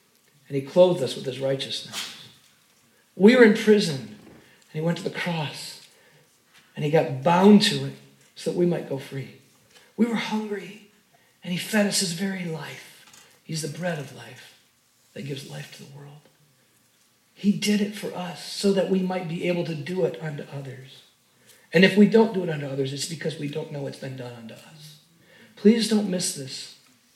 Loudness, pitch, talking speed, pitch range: -23 LUFS, 170 Hz, 195 wpm, 140-195 Hz